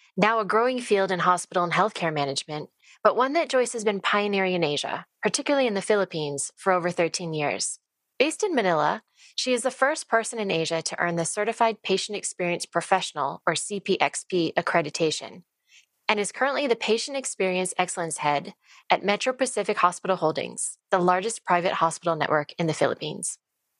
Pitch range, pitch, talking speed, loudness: 165-225 Hz, 190 Hz, 170 wpm, -25 LUFS